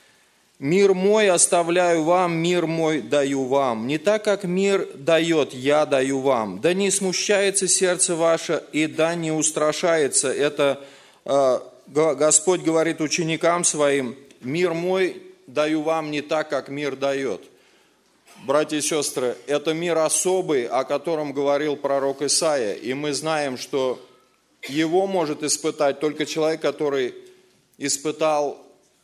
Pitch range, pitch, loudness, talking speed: 145-175 Hz, 155 Hz, -21 LUFS, 130 wpm